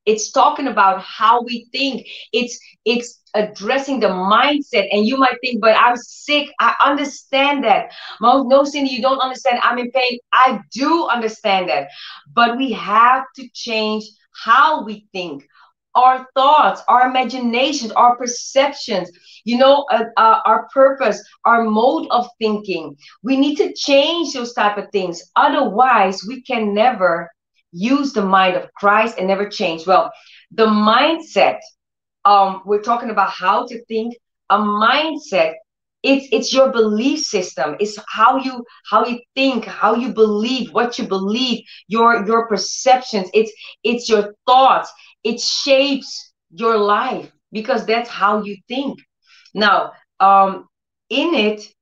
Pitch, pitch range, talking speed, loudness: 235 Hz, 210-260 Hz, 145 wpm, -16 LUFS